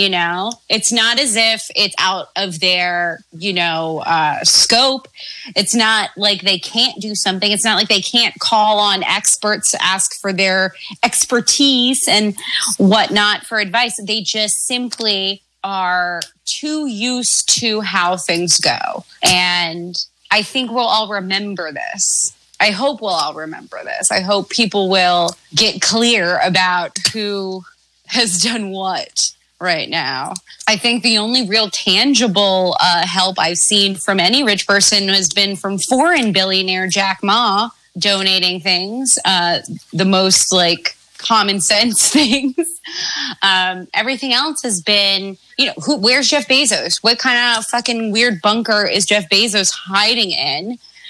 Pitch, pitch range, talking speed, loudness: 205 Hz, 190-235 Hz, 150 wpm, -14 LUFS